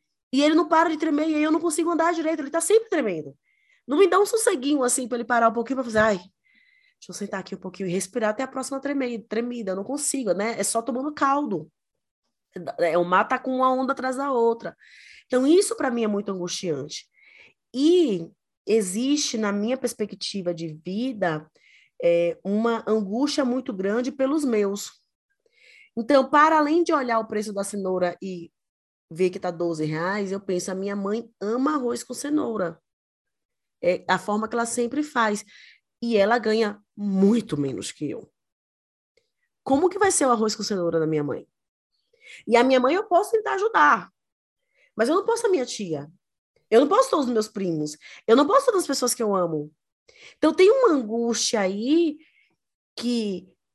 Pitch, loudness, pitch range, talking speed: 240 Hz, -23 LUFS, 200-305 Hz, 185 wpm